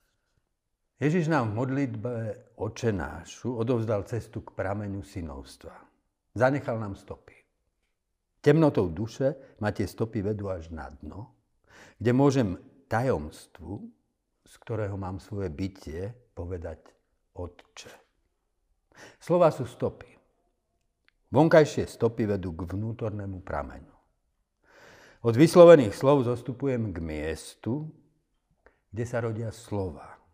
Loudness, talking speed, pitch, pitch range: -26 LUFS, 105 wpm, 110 Hz, 95-130 Hz